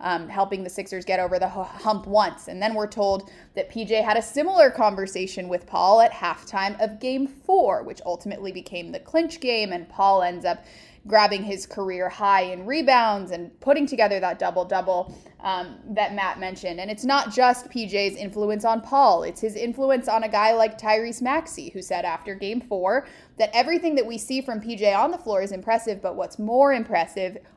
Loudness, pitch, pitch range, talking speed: -23 LUFS, 210 Hz, 190-245 Hz, 200 wpm